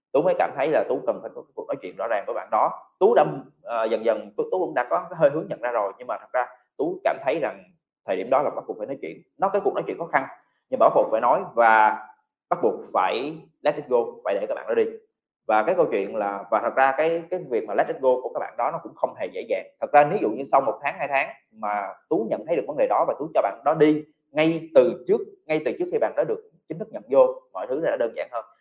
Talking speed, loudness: 300 wpm, -24 LUFS